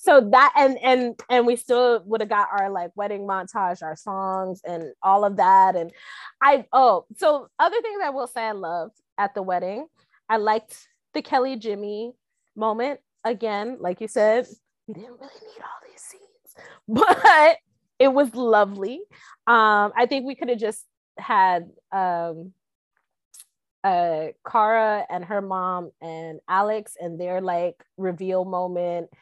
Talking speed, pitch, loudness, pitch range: 155 wpm, 215 Hz, -21 LUFS, 185-255 Hz